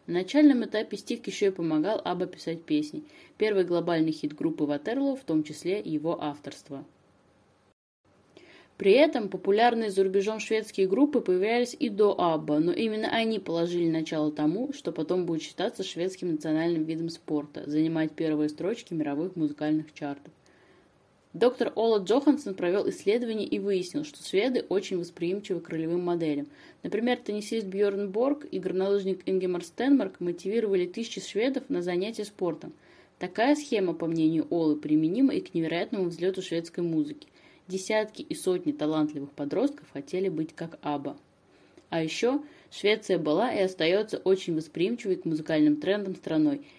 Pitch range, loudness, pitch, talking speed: 160-225 Hz, -28 LUFS, 185 Hz, 145 wpm